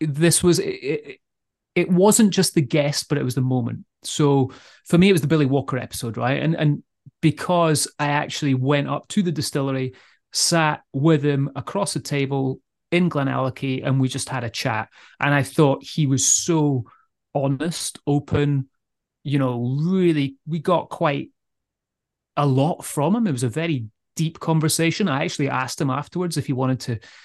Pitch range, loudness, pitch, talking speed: 135-165 Hz, -21 LUFS, 145 Hz, 180 wpm